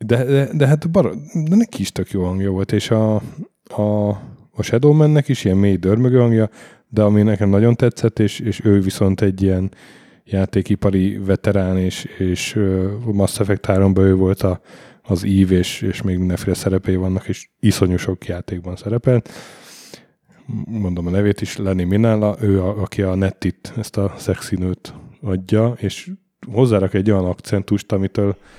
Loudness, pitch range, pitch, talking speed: -18 LUFS, 95-115 Hz, 100 Hz, 160 wpm